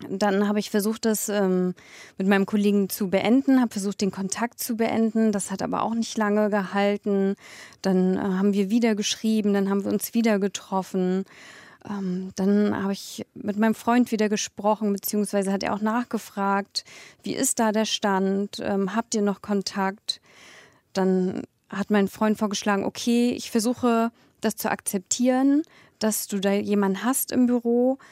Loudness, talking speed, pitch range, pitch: -24 LUFS, 165 wpm, 195-225 Hz, 205 Hz